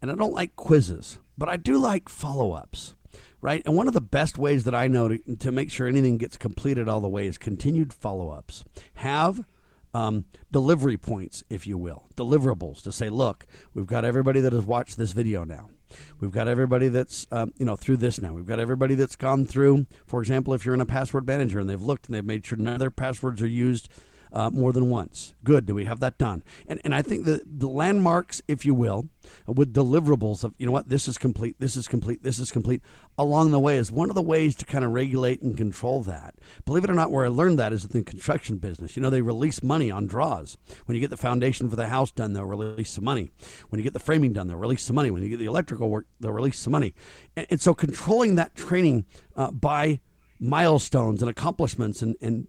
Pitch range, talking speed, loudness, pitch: 110-140 Hz, 235 wpm, -25 LUFS, 125 Hz